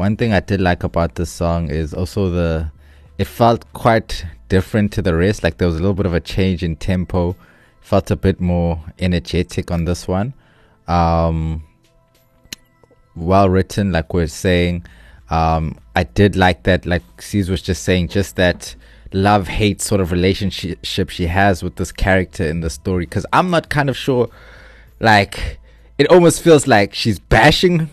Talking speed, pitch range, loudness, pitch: 170 wpm, 85-105 Hz, -17 LUFS, 90 Hz